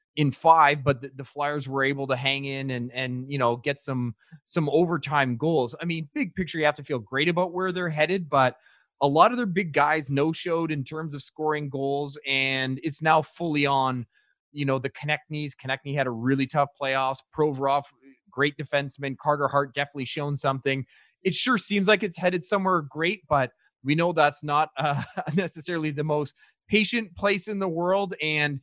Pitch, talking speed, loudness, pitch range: 145 Hz, 195 wpm, -25 LUFS, 135-165 Hz